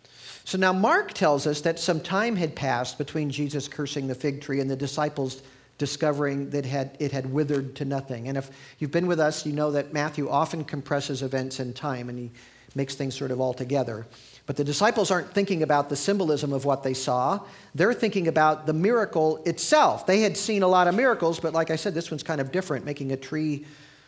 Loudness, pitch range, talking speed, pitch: -26 LUFS, 135-165 Hz, 215 wpm, 145 Hz